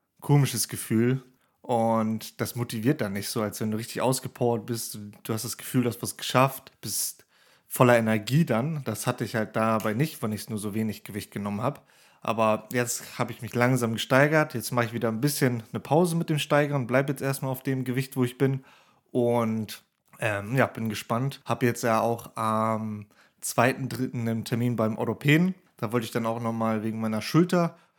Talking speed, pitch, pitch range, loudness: 200 wpm, 120 Hz, 110-130 Hz, -27 LUFS